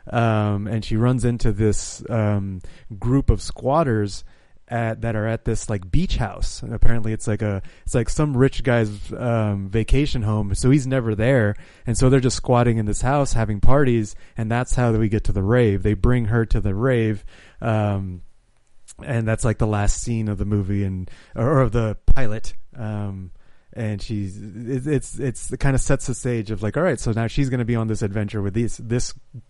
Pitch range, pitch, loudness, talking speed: 105-125 Hz, 115 Hz, -22 LUFS, 205 wpm